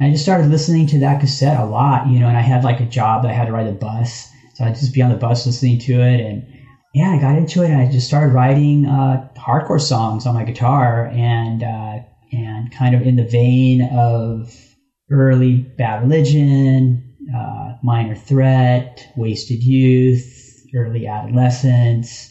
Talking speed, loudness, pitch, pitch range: 190 wpm, -15 LUFS, 125 Hz, 120-135 Hz